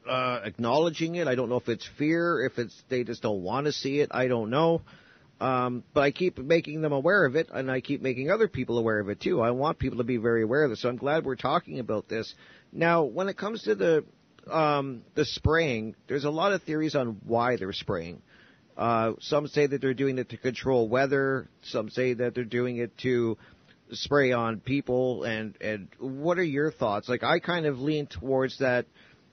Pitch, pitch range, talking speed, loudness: 130 Hz, 120-150 Hz, 220 wpm, -28 LUFS